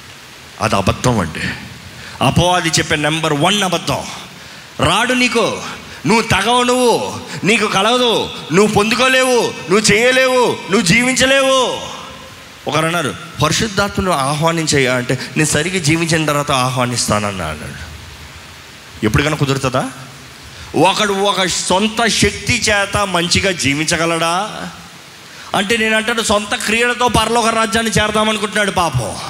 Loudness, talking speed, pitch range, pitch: -14 LUFS, 100 wpm, 135-220 Hz, 175 Hz